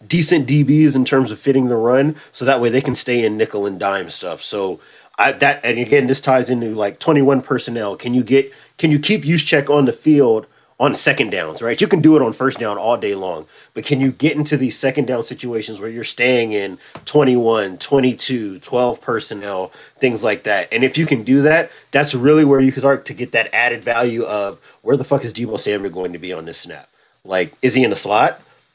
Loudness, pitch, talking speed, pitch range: -16 LUFS, 130 Hz, 230 wpm, 115-145 Hz